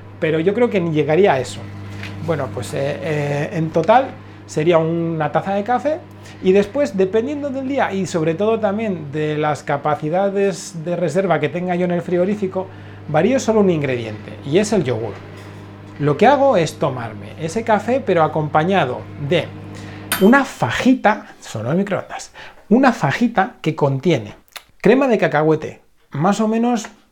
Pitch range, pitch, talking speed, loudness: 145-205 Hz, 170 Hz, 160 wpm, -18 LUFS